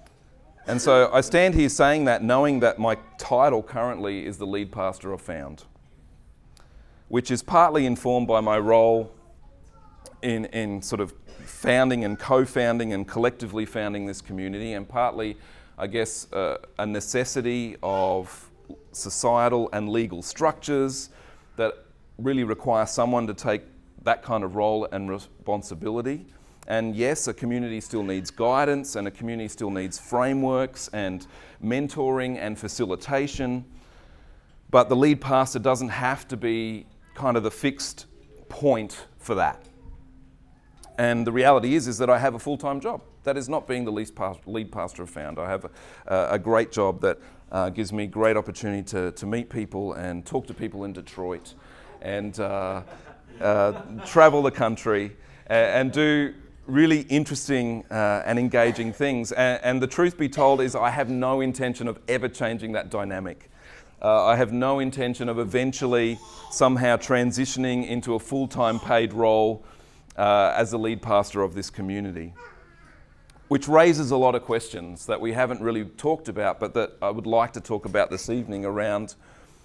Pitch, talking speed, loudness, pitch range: 115 Hz, 160 wpm, -24 LUFS, 105-130 Hz